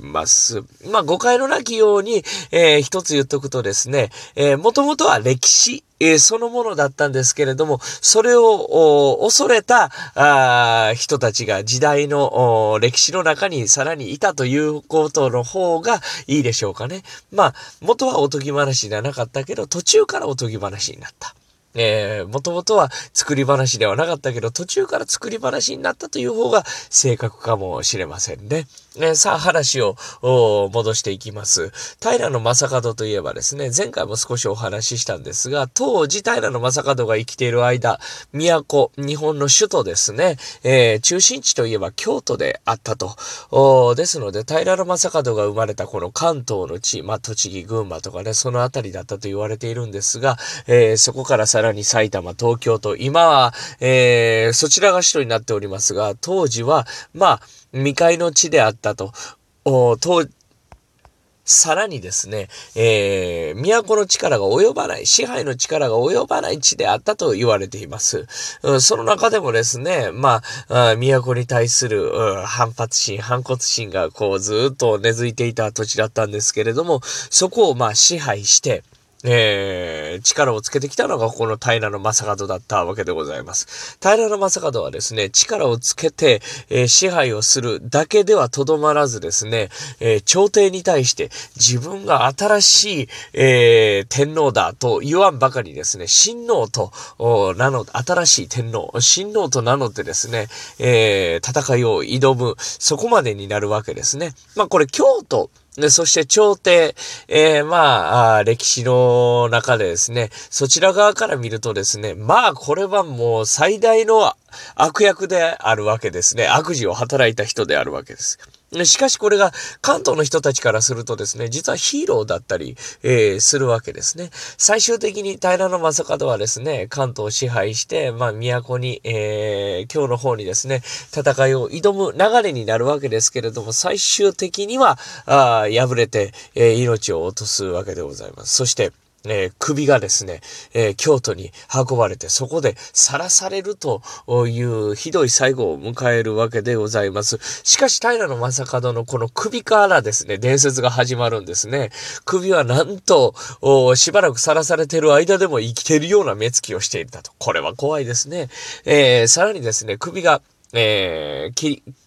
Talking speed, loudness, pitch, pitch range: 320 characters per minute, -17 LUFS, 135 Hz, 115-180 Hz